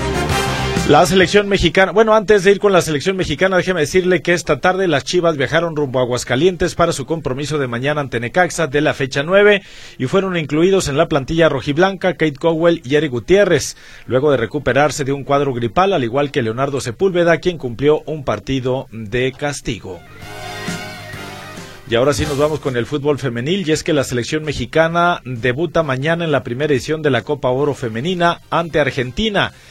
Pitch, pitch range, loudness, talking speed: 150 Hz, 130-175 Hz, -16 LUFS, 185 wpm